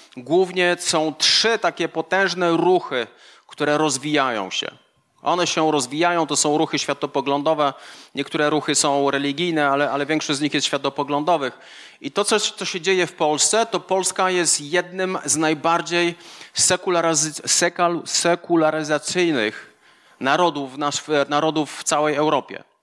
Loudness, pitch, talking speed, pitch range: -20 LUFS, 155 Hz, 125 wpm, 145-175 Hz